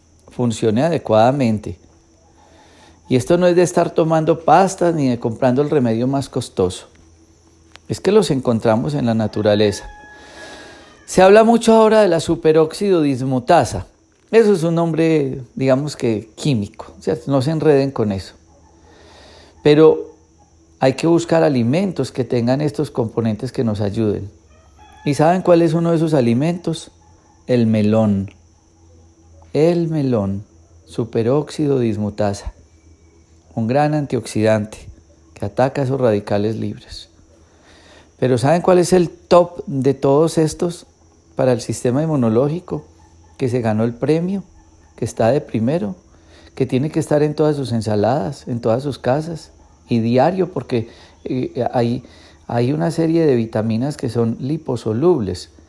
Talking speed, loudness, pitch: 135 wpm, -17 LUFS, 120 Hz